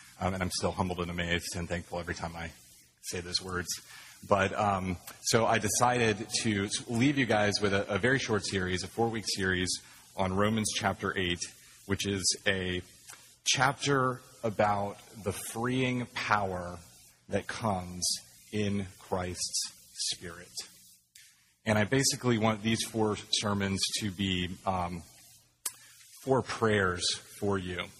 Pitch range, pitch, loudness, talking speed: 90-110 Hz, 100 Hz, -31 LUFS, 140 wpm